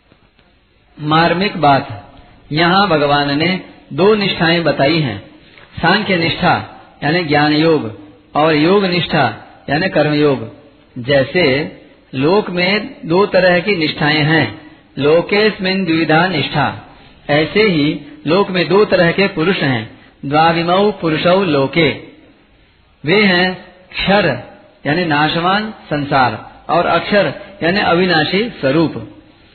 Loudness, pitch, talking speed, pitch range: -14 LUFS, 165 Hz, 110 wpm, 145-185 Hz